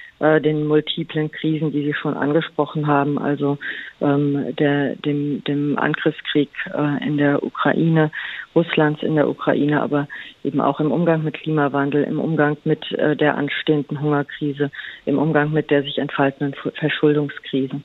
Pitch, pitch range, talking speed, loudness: 145 Hz, 145-155 Hz, 140 wpm, -20 LUFS